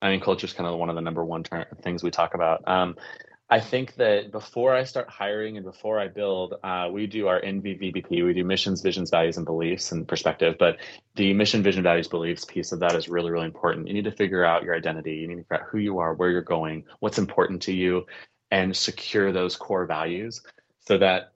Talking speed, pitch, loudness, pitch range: 235 wpm, 90 Hz, -25 LUFS, 85-100 Hz